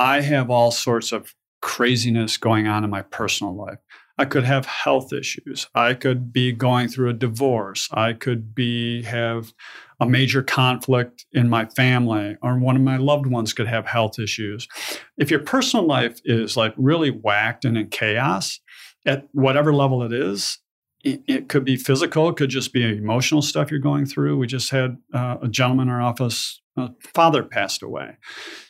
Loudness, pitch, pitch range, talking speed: -21 LUFS, 125 Hz, 115-135 Hz, 185 wpm